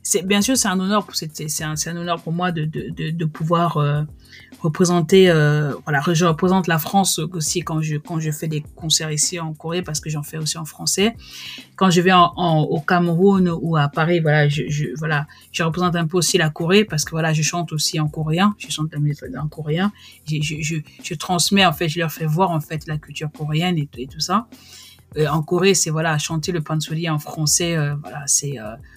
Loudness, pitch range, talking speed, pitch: -19 LUFS, 150-175 Hz, 235 wpm, 160 Hz